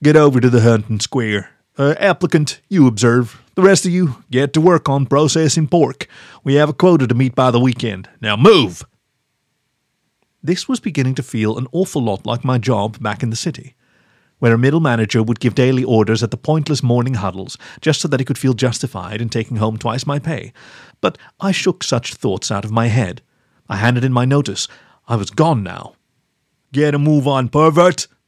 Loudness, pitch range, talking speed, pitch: -16 LUFS, 115-150 Hz, 200 wpm, 130 Hz